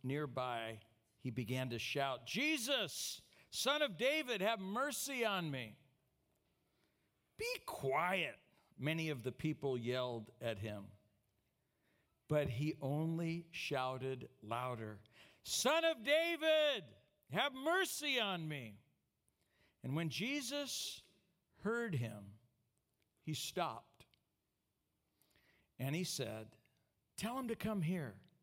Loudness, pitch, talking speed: -40 LUFS, 145 Hz, 105 wpm